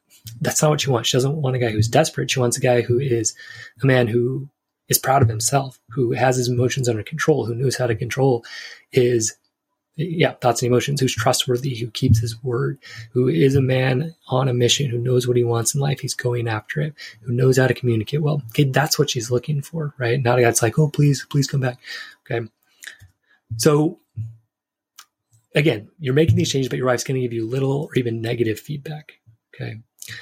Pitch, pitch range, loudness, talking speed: 125 Hz, 120-140 Hz, -20 LUFS, 215 wpm